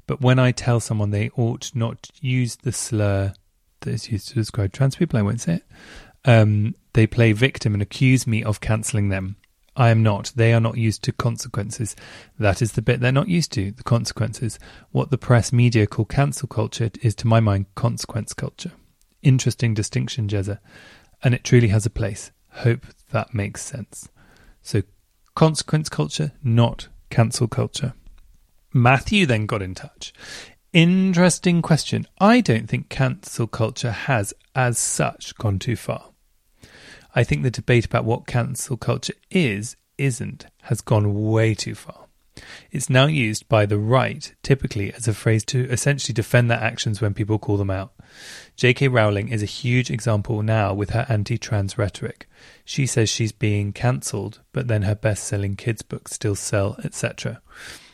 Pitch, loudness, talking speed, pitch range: 115 Hz, -21 LUFS, 170 wpm, 105-130 Hz